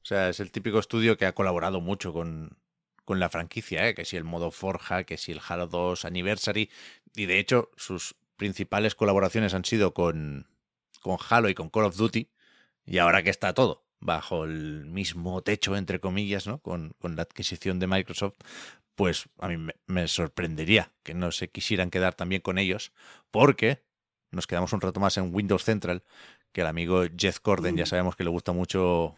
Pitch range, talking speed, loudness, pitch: 85-100 Hz, 195 wpm, -28 LUFS, 95 Hz